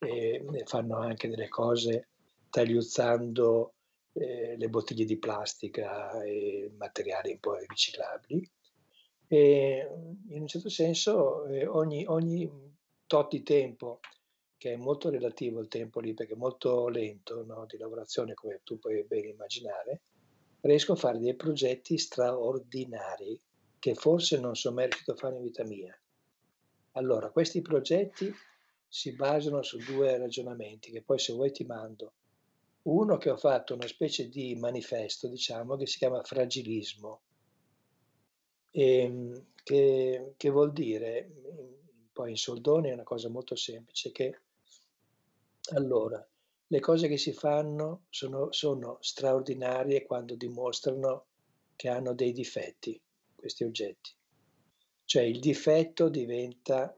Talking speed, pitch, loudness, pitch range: 130 wpm, 130 Hz, -31 LUFS, 120-150 Hz